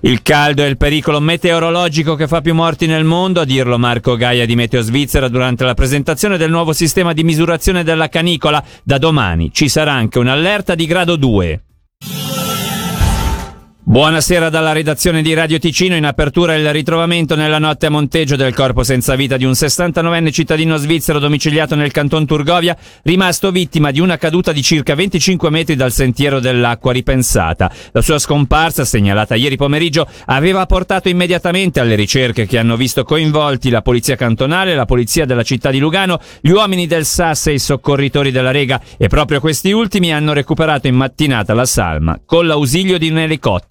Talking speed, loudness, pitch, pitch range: 175 wpm, -13 LUFS, 150 Hz, 130-165 Hz